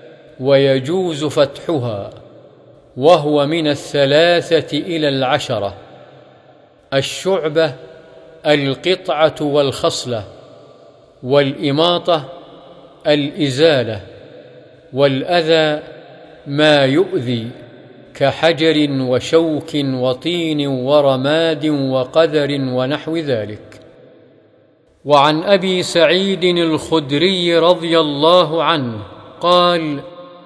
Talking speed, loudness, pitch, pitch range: 60 wpm, -15 LUFS, 150 Hz, 135-165 Hz